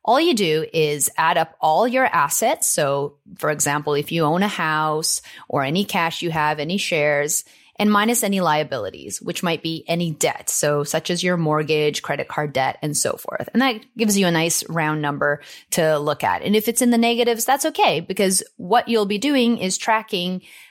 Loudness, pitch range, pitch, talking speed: -20 LUFS, 150-210 Hz, 170 Hz, 205 wpm